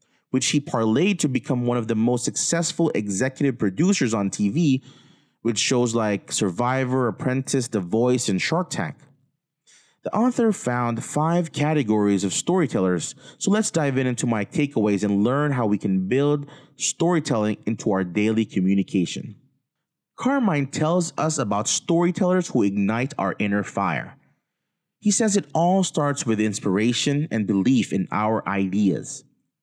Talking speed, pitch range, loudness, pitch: 145 wpm, 110-155 Hz, -22 LUFS, 130 Hz